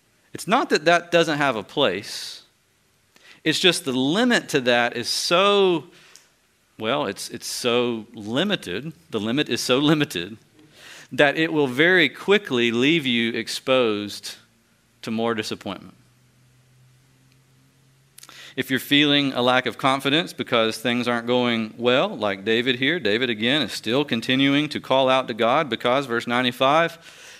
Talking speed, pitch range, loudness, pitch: 140 wpm, 120-145 Hz, -21 LUFS, 130 Hz